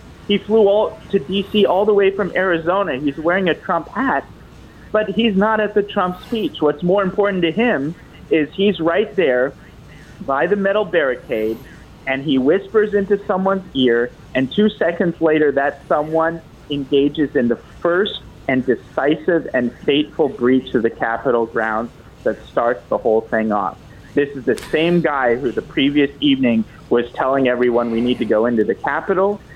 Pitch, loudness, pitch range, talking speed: 165 Hz, -18 LUFS, 135-200 Hz, 175 wpm